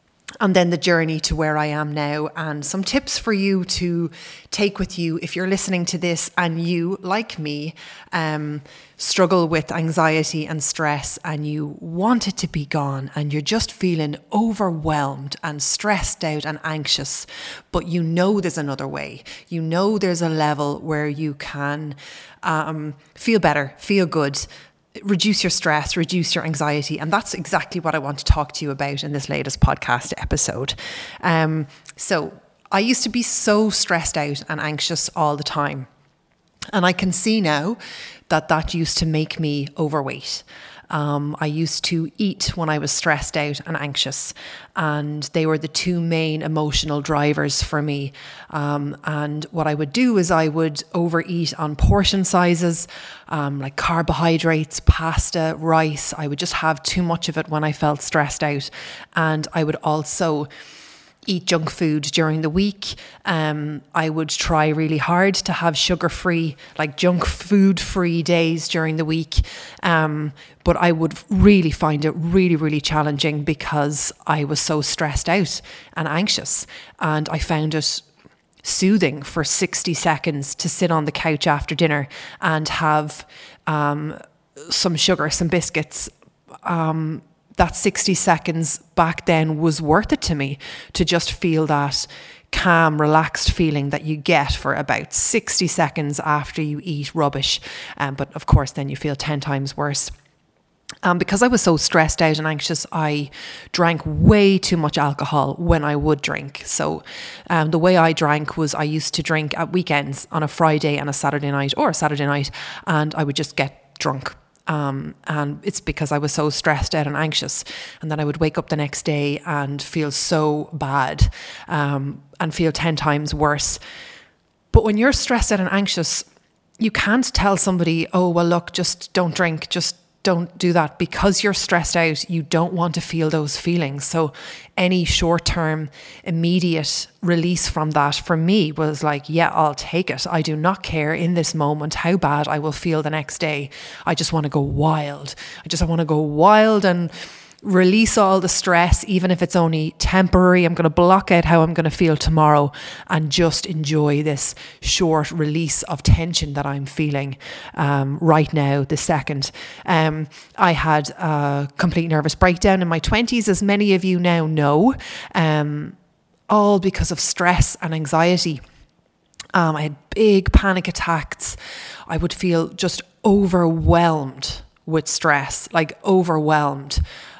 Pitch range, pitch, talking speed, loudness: 150-175 Hz, 160 Hz, 170 wpm, -20 LUFS